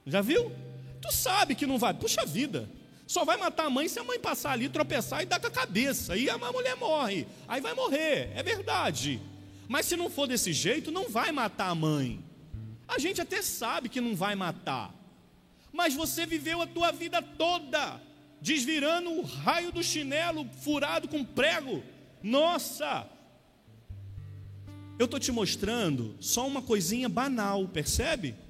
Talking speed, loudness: 165 wpm, -30 LUFS